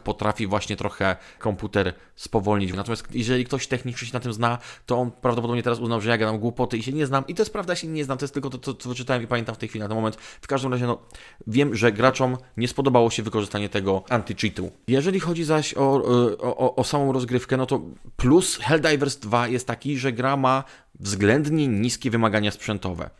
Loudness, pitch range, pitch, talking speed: -24 LUFS, 110-135 Hz, 120 Hz, 220 wpm